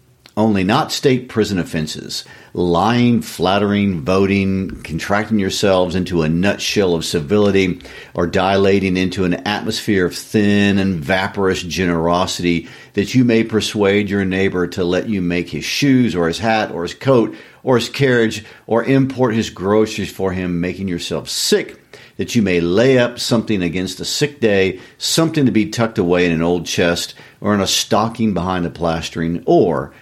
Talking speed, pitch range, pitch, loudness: 165 wpm, 90-110 Hz, 95 Hz, -17 LUFS